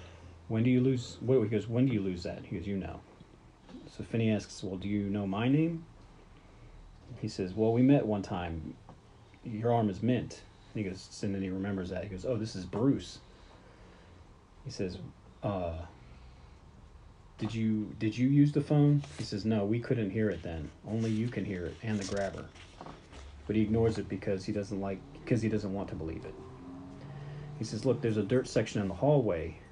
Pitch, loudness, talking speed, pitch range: 105 Hz, -32 LUFS, 205 wpm, 90-115 Hz